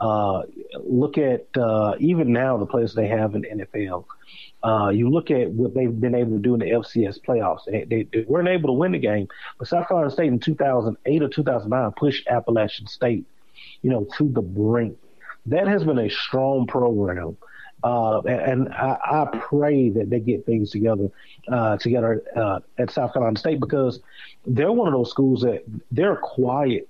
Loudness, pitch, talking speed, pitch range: -22 LUFS, 120 Hz, 190 wpm, 110-135 Hz